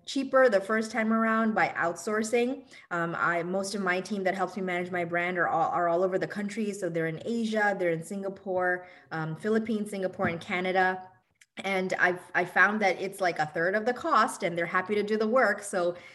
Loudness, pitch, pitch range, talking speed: -28 LUFS, 190 Hz, 175-215 Hz, 215 wpm